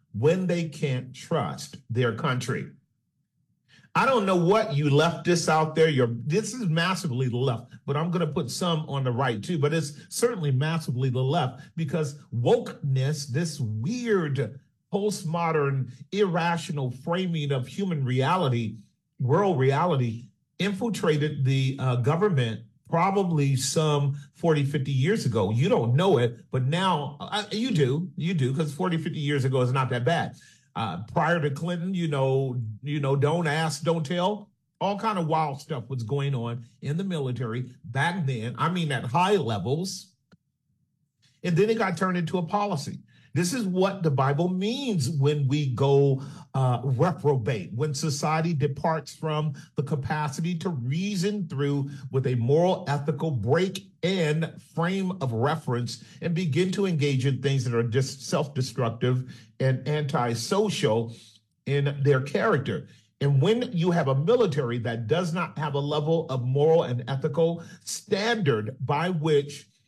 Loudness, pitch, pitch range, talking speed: -26 LUFS, 150 Hz, 135-175 Hz, 155 wpm